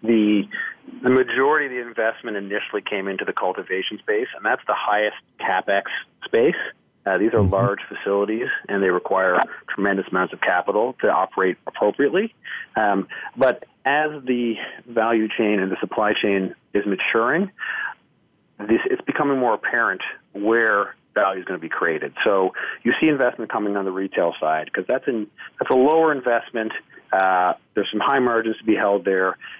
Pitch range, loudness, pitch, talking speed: 100-125 Hz, -21 LUFS, 110 Hz, 165 wpm